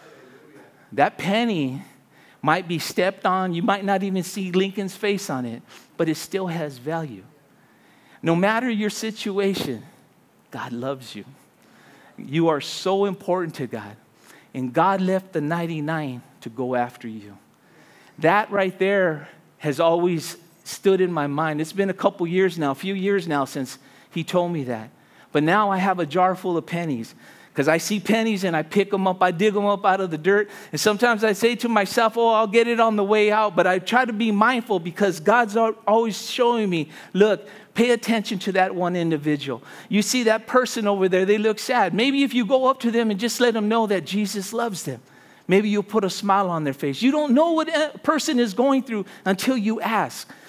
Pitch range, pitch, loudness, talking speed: 165-220 Hz, 195 Hz, -22 LUFS, 200 wpm